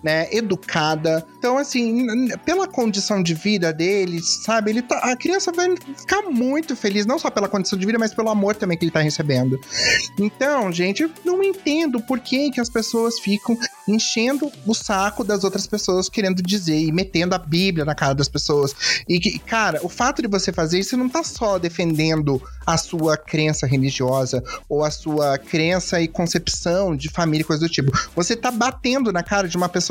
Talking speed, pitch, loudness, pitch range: 195 wpm, 195 Hz, -20 LUFS, 165-240 Hz